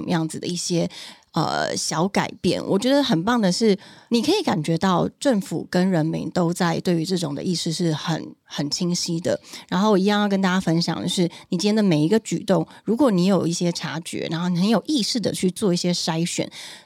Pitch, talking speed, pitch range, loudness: 175 Hz, 315 characters per minute, 165-200 Hz, -22 LUFS